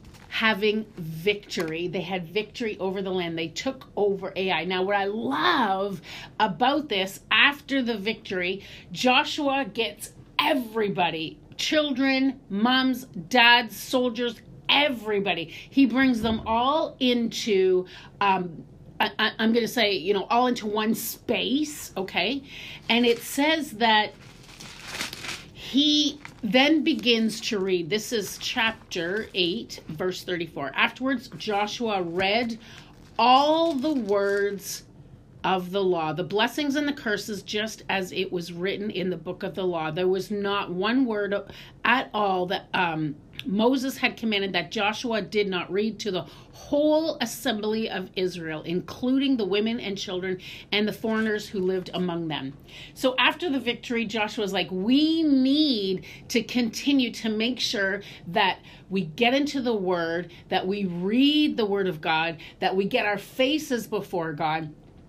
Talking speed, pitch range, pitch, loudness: 145 wpm, 185-245 Hz, 210 Hz, -25 LUFS